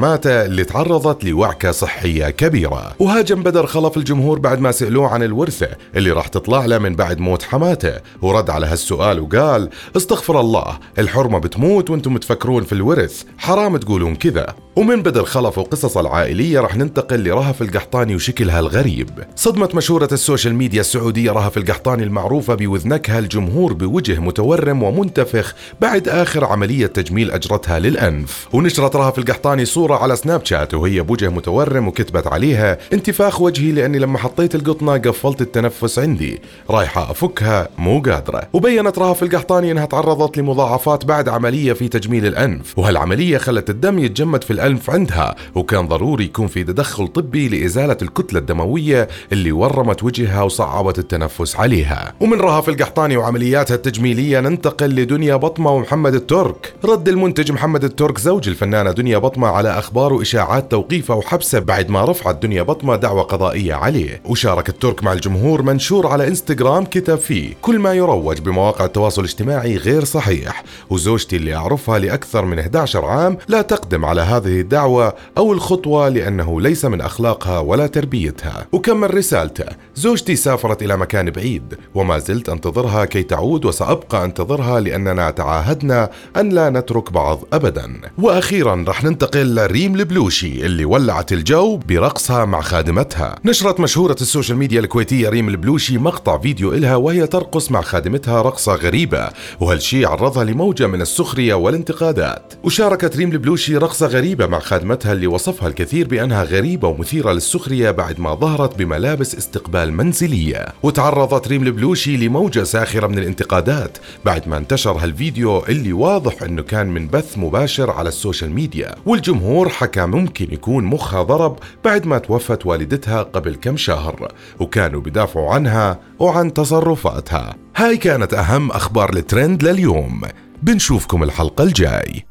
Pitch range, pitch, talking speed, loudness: 100-150 Hz, 125 Hz, 145 wpm, -16 LUFS